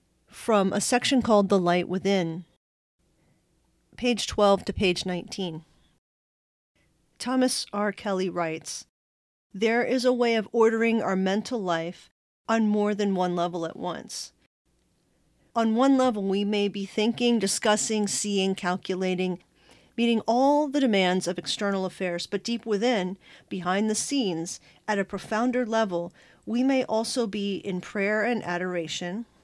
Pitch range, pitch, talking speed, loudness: 180-230 Hz, 205 Hz, 135 wpm, -26 LUFS